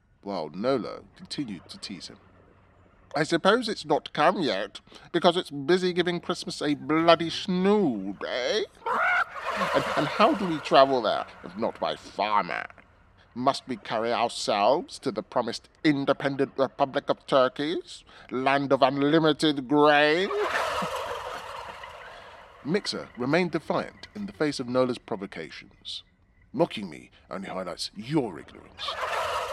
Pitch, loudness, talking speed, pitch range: 150 Hz, -26 LUFS, 125 wpm, 135-180 Hz